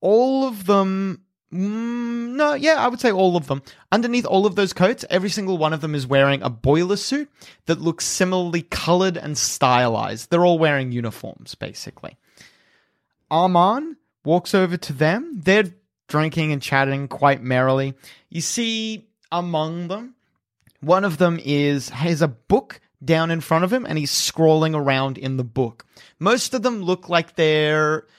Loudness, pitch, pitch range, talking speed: -20 LUFS, 170 Hz, 145-200 Hz, 165 wpm